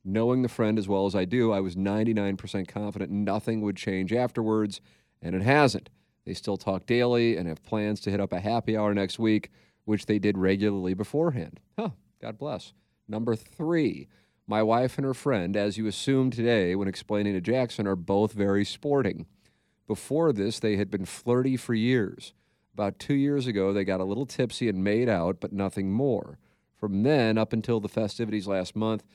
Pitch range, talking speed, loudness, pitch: 100-120 Hz, 190 wpm, -27 LUFS, 105 Hz